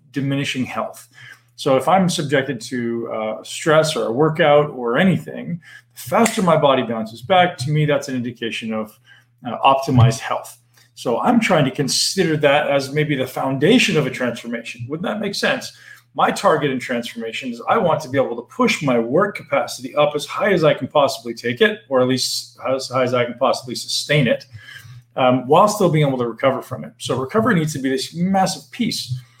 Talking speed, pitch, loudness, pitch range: 200 wpm, 135 Hz, -19 LUFS, 120-155 Hz